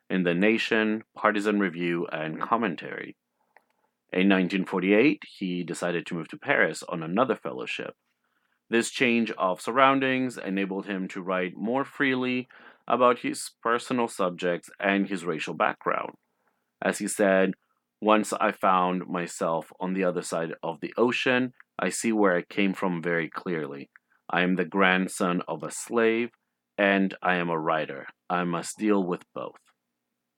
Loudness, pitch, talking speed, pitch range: -26 LUFS, 95 Hz, 150 wpm, 90-110 Hz